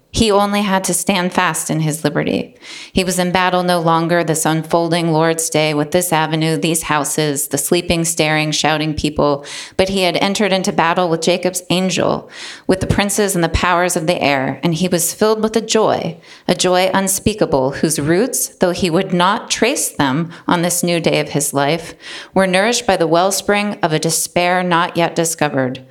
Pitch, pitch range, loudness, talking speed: 175 Hz, 160-185 Hz, -16 LUFS, 190 wpm